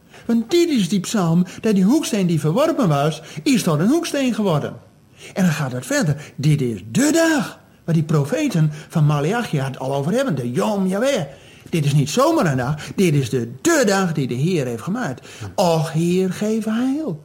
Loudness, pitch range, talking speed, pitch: -19 LUFS, 145-220 Hz, 200 wpm, 170 Hz